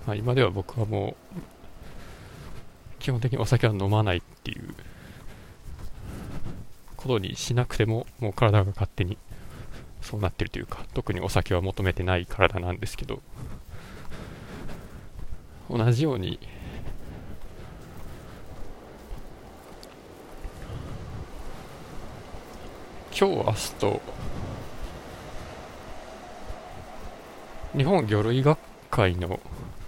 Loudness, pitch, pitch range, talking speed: -27 LUFS, 100 Hz, 90-115 Hz, 165 characters per minute